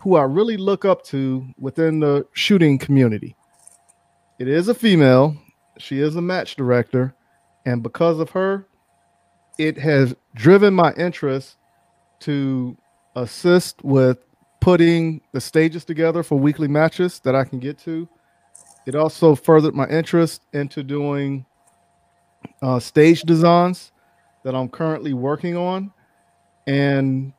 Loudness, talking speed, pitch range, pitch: -18 LUFS, 130 wpm, 135-170 Hz, 150 Hz